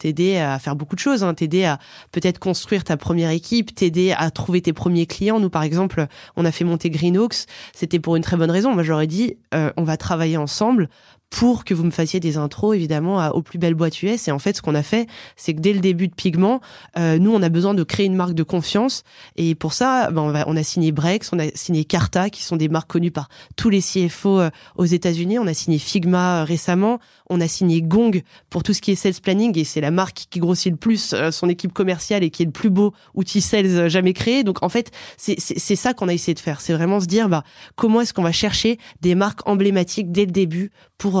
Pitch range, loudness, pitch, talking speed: 165-200 Hz, -20 LUFS, 180 Hz, 260 wpm